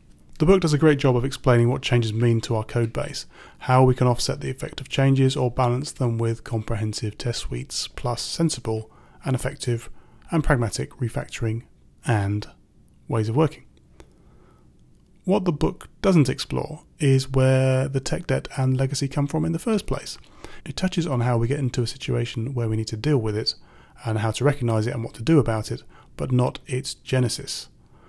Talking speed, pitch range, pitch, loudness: 190 wpm, 115-135 Hz, 125 Hz, -23 LUFS